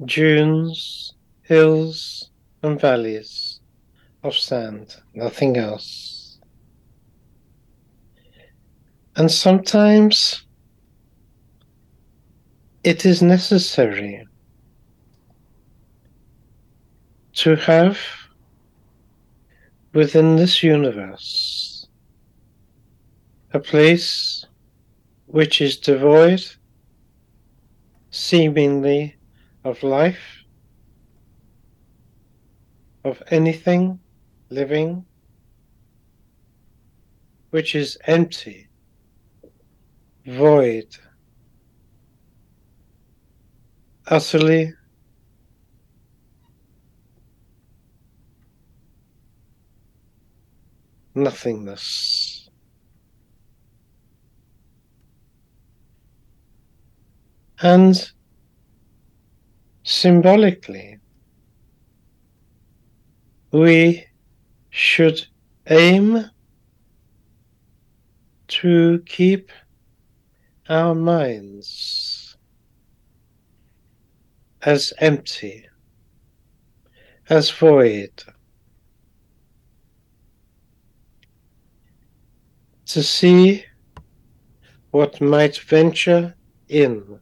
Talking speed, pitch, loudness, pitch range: 35 wpm, 130 Hz, -17 LUFS, 110-160 Hz